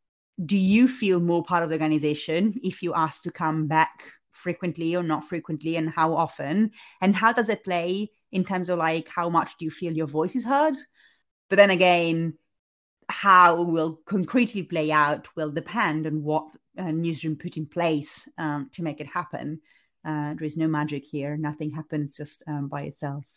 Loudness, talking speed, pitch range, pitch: -25 LUFS, 190 wpm, 155-180 Hz, 165 Hz